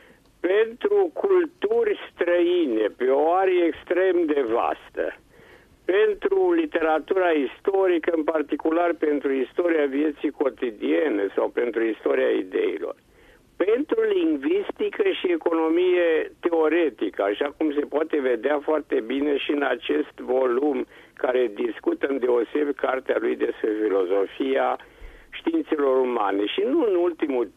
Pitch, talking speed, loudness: 335 Hz, 115 wpm, -23 LUFS